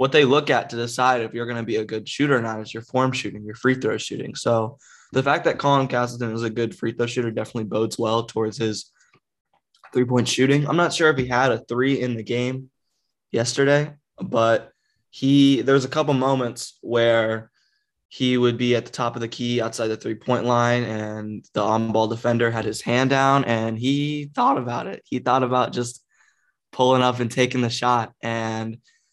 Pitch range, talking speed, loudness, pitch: 115-130 Hz, 210 wpm, -22 LUFS, 120 Hz